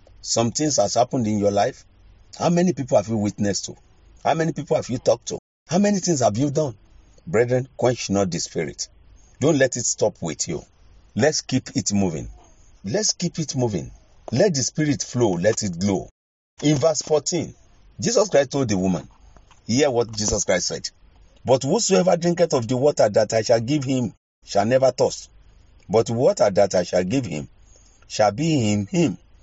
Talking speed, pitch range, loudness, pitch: 190 wpm, 95-150 Hz, -21 LUFS, 120 Hz